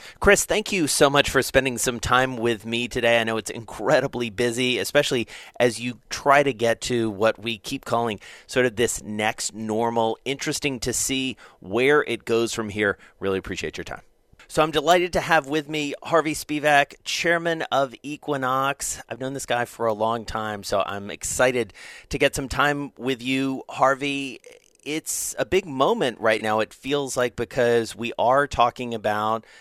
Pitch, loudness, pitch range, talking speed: 125 Hz, -23 LUFS, 115-145 Hz, 180 wpm